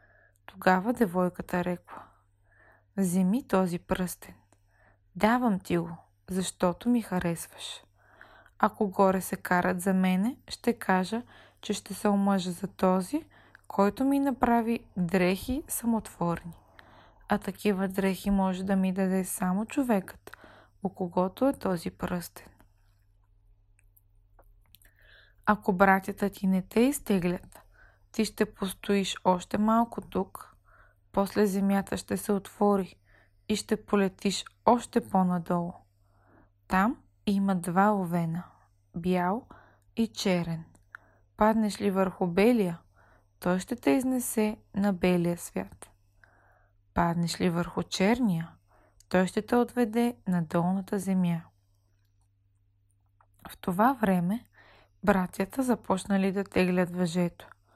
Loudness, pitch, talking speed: -28 LUFS, 185 Hz, 110 wpm